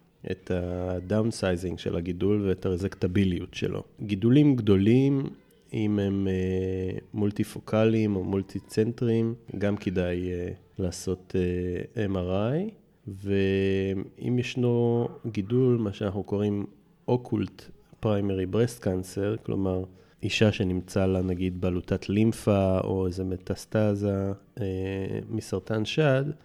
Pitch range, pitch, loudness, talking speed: 95-110 Hz, 100 Hz, -27 LUFS, 100 wpm